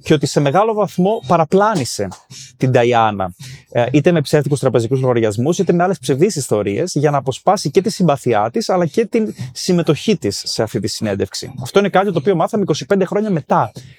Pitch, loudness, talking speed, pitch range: 160 Hz, -16 LUFS, 185 wpm, 130-190 Hz